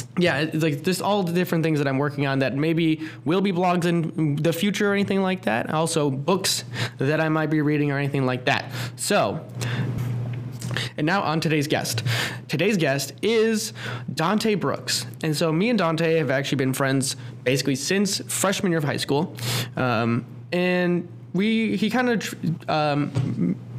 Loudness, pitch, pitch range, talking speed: -23 LUFS, 150 Hz, 130-175 Hz, 170 wpm